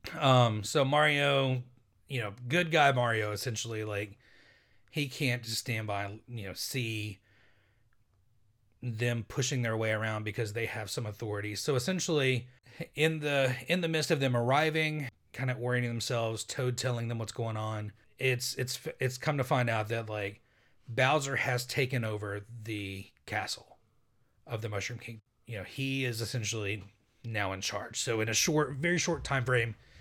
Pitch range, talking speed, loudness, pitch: 110-130 Hz, 165 wpm, -31 LUFS, 120 Hz